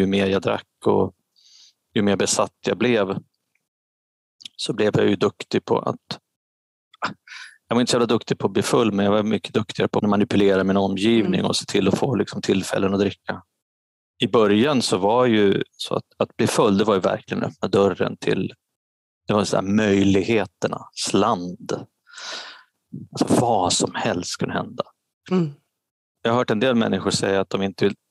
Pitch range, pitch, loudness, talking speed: 95-115 Hz, 100 Hz, -21 LUFS, 185 wpm